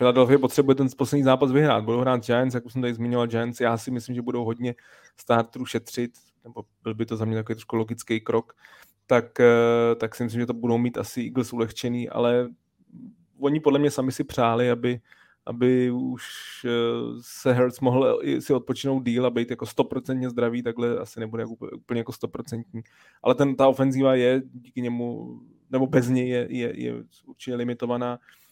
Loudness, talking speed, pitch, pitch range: -24 LUFS, 185 wpm, 120 Hz, 115-130 Hz